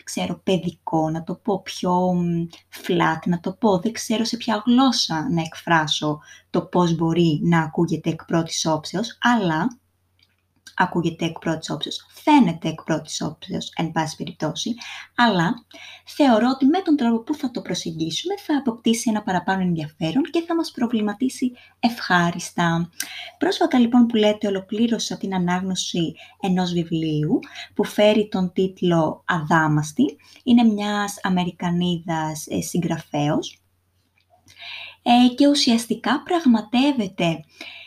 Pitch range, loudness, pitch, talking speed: 165-240 Hz, -21 LUFS, 190 Hz, 125 wpm